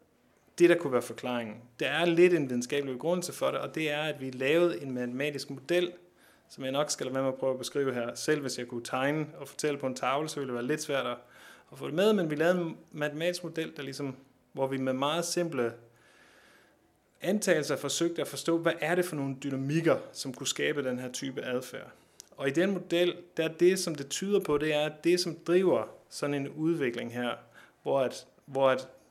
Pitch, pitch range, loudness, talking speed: 145 Hz, 130-170 Hz, -30 LUFS, 225 wpm